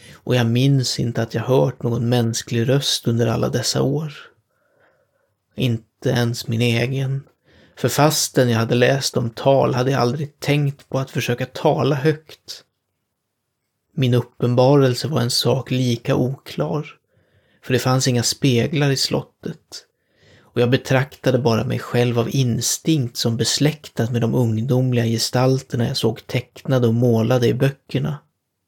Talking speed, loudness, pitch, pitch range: 145 wpm, -19 LUFS, 125 Hz, 120-135 Hz